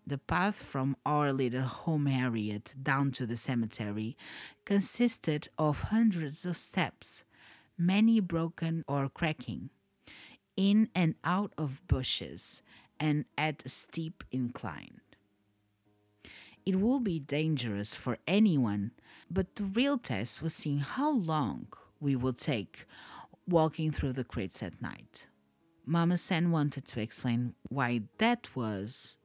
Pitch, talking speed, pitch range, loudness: 145 Hz, 125 wpm, 120-170 Hz, -32 LUFS